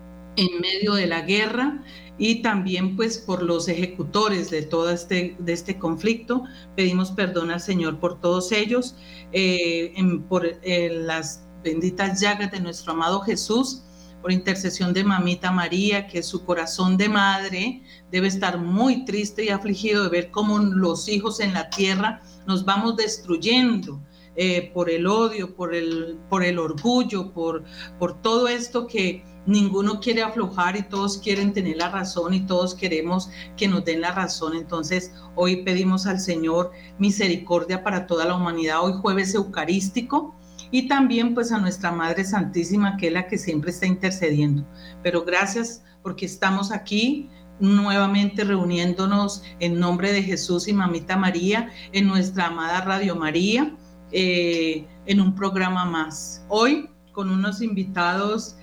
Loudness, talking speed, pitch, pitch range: -23 LUFS, 150 wpm, 185 Hz, 175-205 Hz